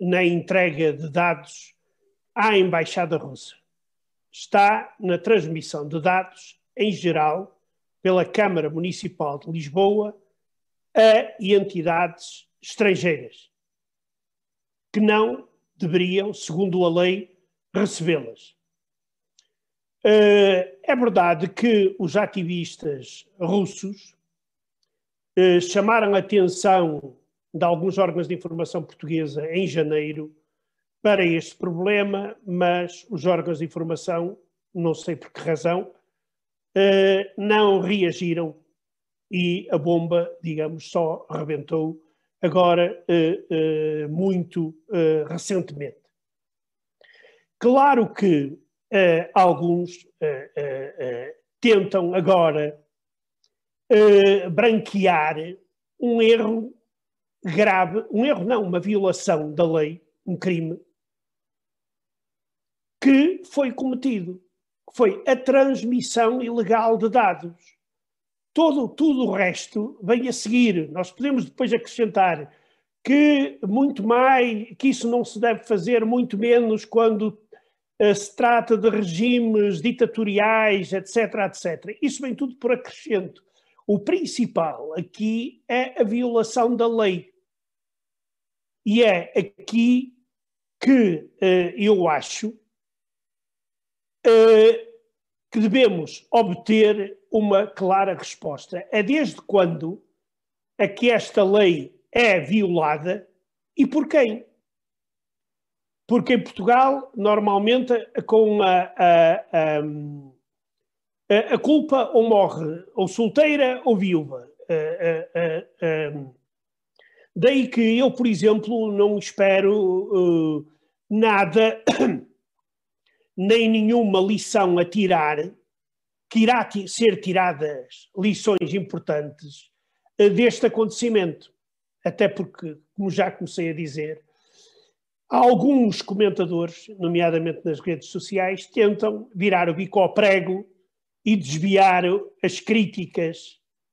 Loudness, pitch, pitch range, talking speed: -21 LUFS, 195 Hz, 175-230 Hz, 95 wpm